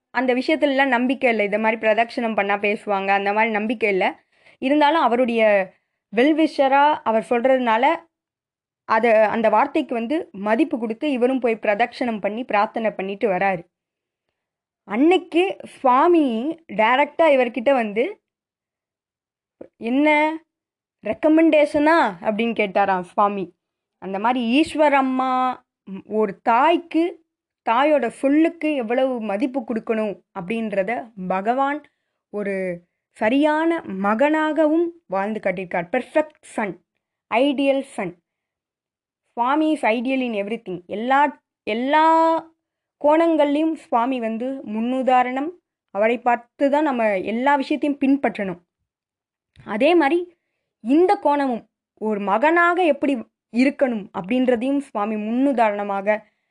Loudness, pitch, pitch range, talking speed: -20 LUFS, 250 Hz, 215-295 Hz, 100 wpm